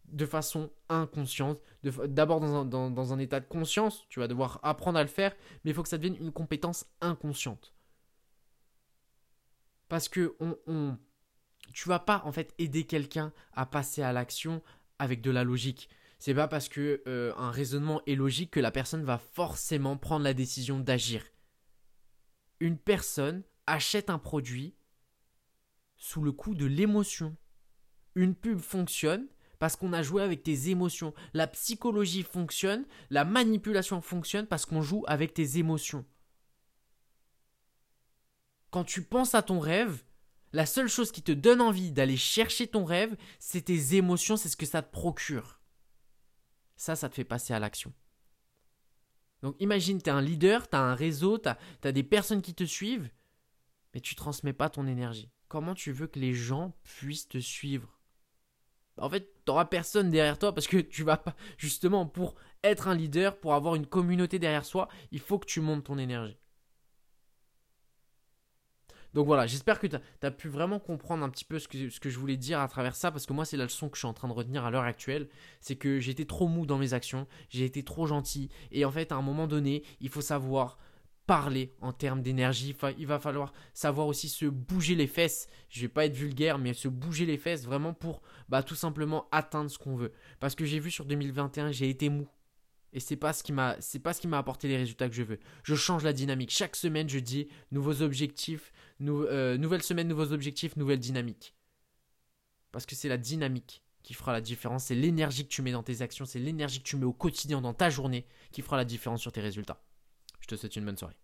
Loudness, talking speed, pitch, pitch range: -32 LUFS, 195 wpm, 150 Hz, 135-165 Hz